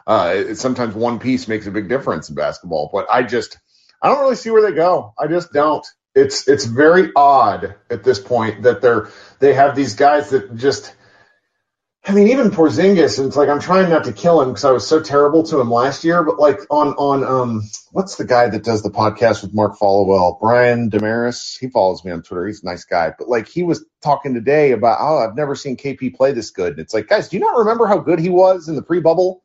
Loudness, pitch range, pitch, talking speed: -16 LUFS, 115-175 Hz, 140 Hz, 240 wpm